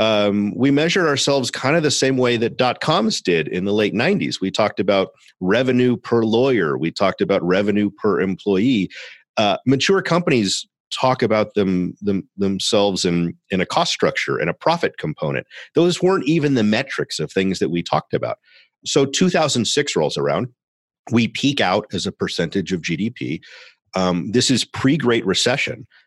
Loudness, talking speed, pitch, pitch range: -19 LUFS, 175 wpm, 115 Hz, 100-135 Hz